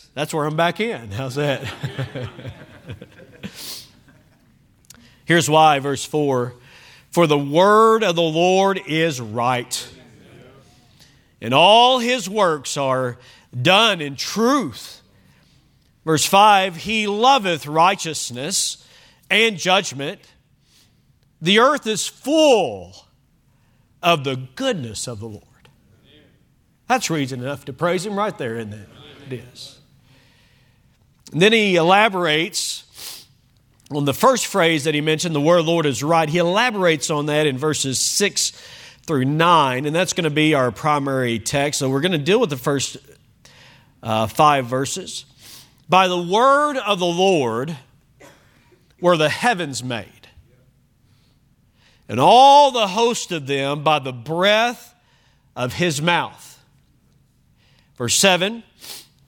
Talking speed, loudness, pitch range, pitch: 130 wpm, -18 LUFS, 130-175 Hz, 145 Hz